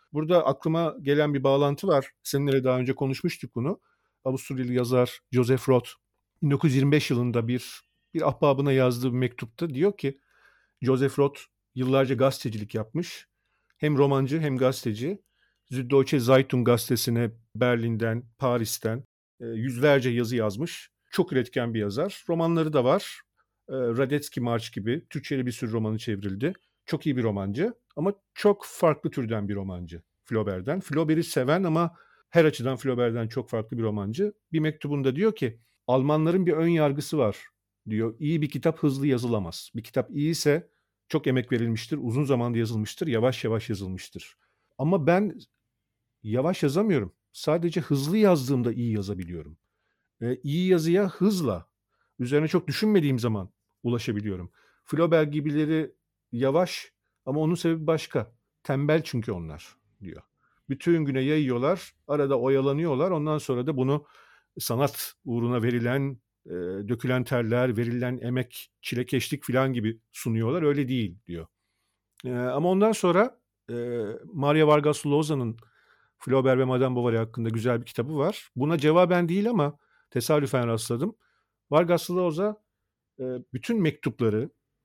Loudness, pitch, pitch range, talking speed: -26 LUFS, 135 Hz, 120-155 Hz, 130 wpm